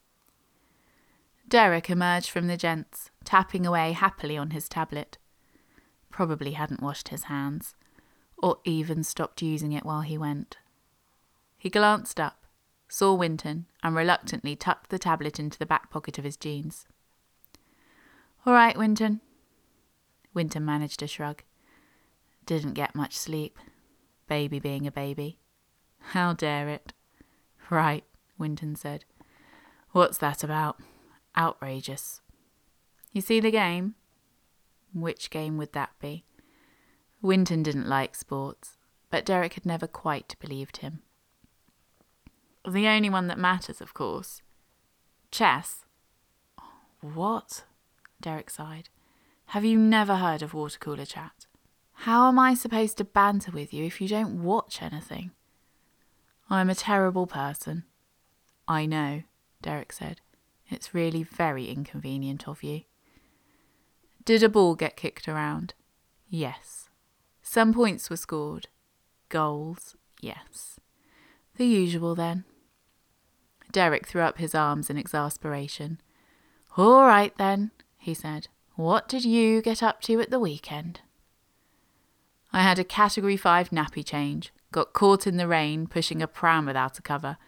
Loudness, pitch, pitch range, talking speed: -26 LUFS, 165 Hz, 150-195 Hz, 130 wpm